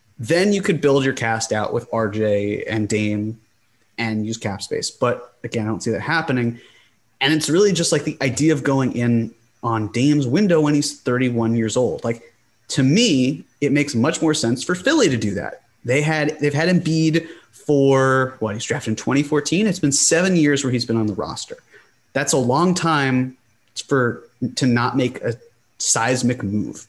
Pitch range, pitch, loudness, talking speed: 115-150 Hz, 130 Hz, -19 LUFS, 190 wpm